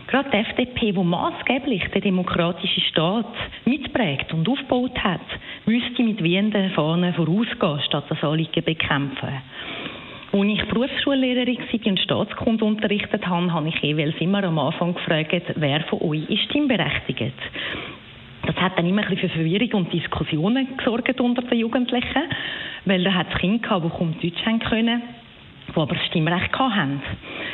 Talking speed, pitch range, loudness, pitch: 155 wpm, 165-230 Hz, -22 LUFS, 190 Hz